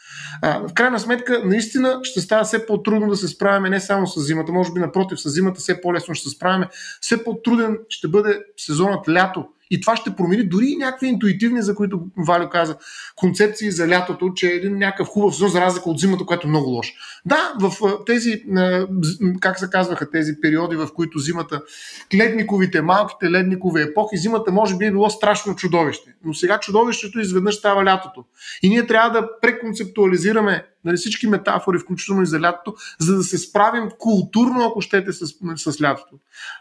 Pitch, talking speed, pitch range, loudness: 190 Hz, 180 wpm, 175-215 Hz, -19 LUFS